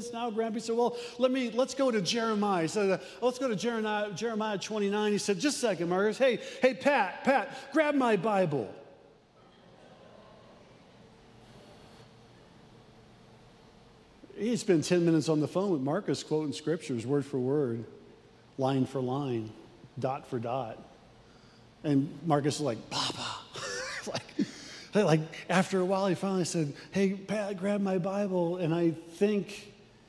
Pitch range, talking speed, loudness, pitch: 155-220 Hz, 145 wpm, -30 LUFS, 195 Hz